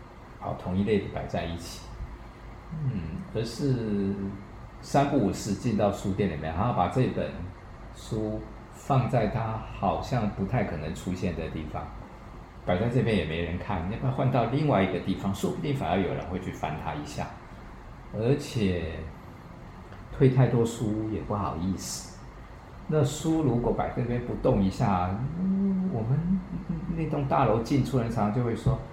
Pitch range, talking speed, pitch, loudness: 95-135 Hz, 230 characters per minute, 110 Hz, -28 LUFS